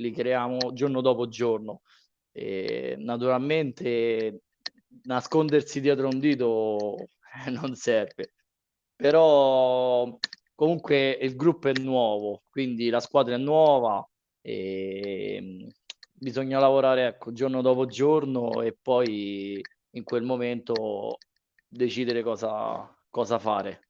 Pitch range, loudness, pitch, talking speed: 120-135 Hz, -26 LUFS, 125 Hz, 100 wpm